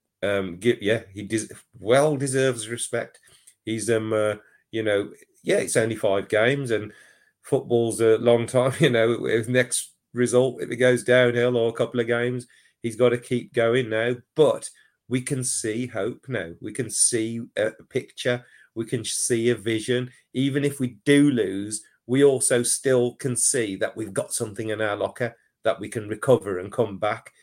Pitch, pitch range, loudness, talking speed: 120 Hz, 110-125 Hz, -23 LUFS, 175 wpm